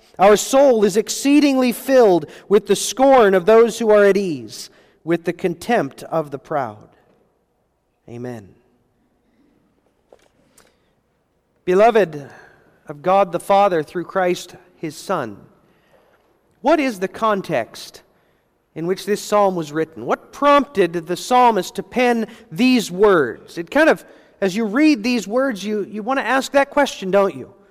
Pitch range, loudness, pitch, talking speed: 175-240 Hz, -17 LUFS, 200 Hz, 140 wpm